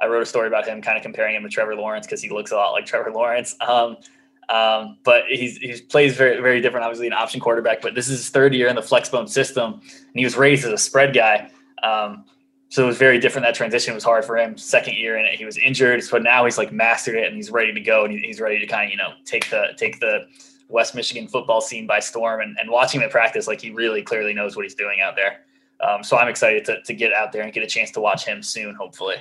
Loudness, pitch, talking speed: -19 LUFS, 120 Hz, 275 wpm